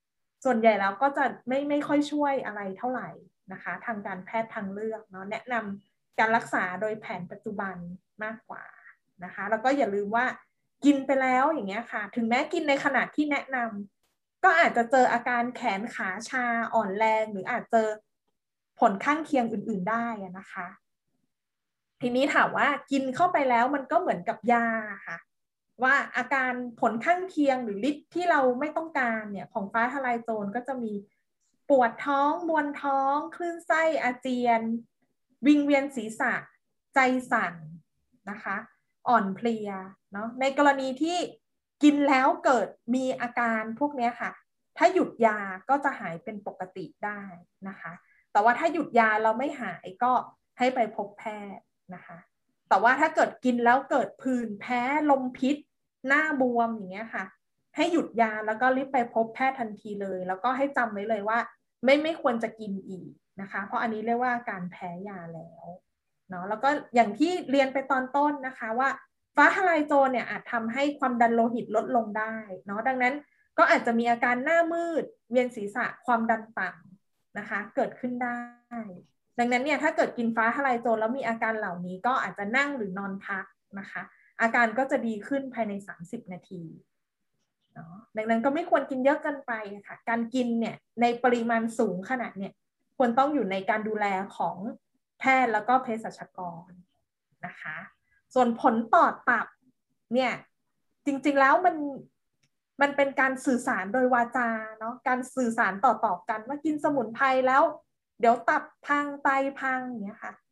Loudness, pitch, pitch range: -27 LUFS, 235 Hz, 215-270 Hz